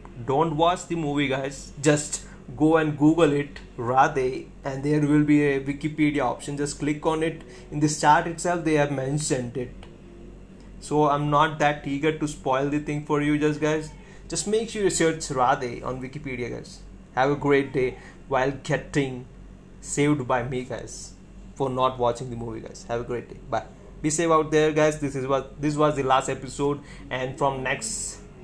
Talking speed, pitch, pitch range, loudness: 190 wpm, 145 Hz, 135-155 Hz, -25 LUFS